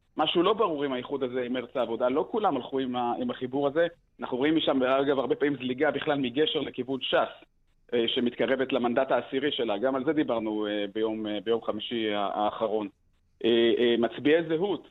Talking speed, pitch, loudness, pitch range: 160 wpm, 130 Hz, -28 LUFS, 115-145 Hz